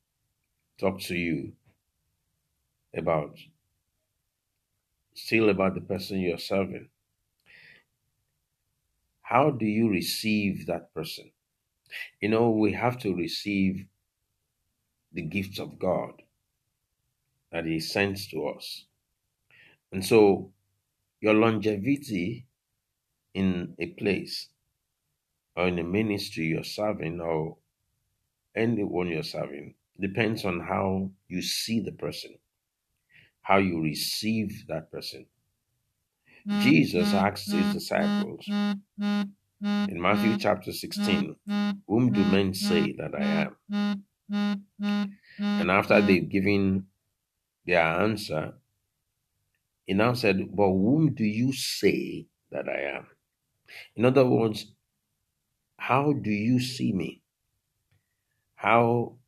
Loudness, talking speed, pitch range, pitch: -27 LUFS, 100 wpm, 95-130 Hz, 105 Hz